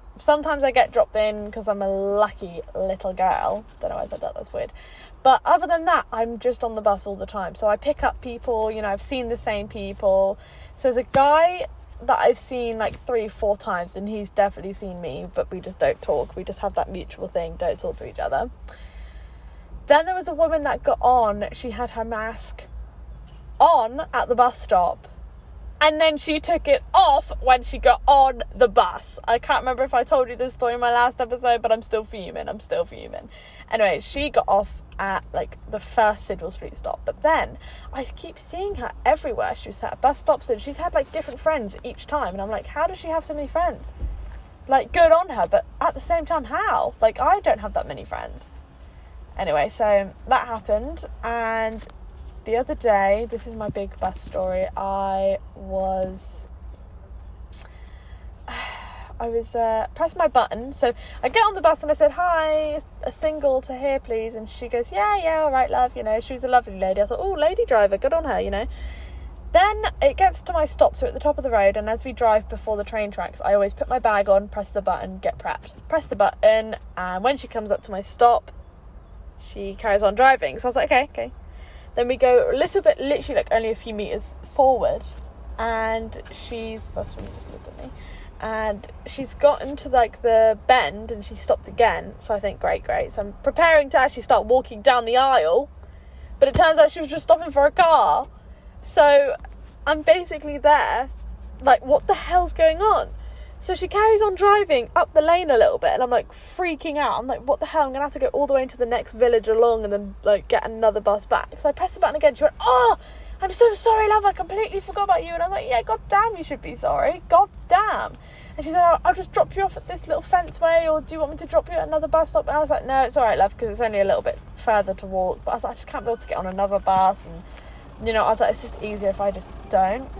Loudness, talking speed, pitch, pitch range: -21 LUFS, 235 wpm, 250 Hz, 205-315 Hz